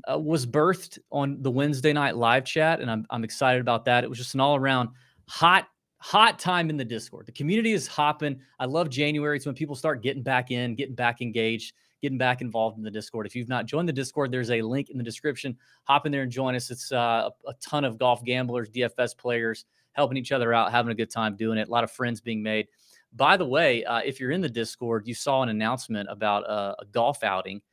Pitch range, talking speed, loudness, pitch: 115-140 Hz, 240 wpm, -26 LUFS, 125 Hz